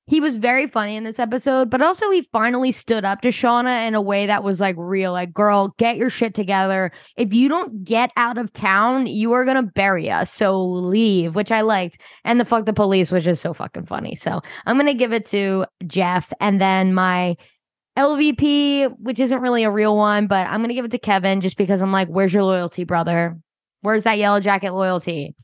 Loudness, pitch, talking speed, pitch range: -19 LUFS, 210 Hz, 215 wpm, 190-240 Hz